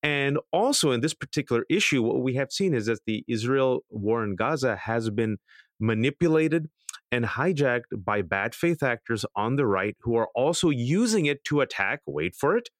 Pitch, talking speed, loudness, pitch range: 130 Hz, 185 wpm, -26 LUFS, 115-155 Hz